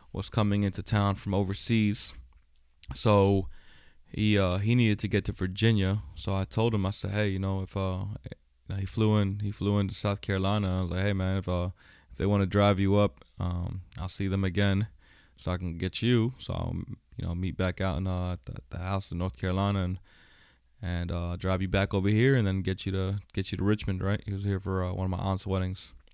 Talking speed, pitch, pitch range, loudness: 230 wpm, 95 Hz, 90-100 Hz, -29 LUFS